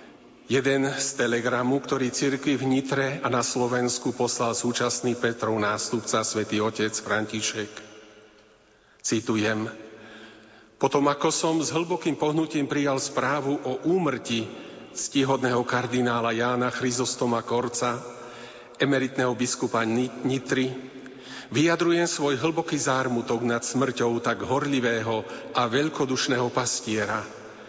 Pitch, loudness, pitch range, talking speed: 125 Hz, -25 LUFS, 115-135 Hz, 100 wpm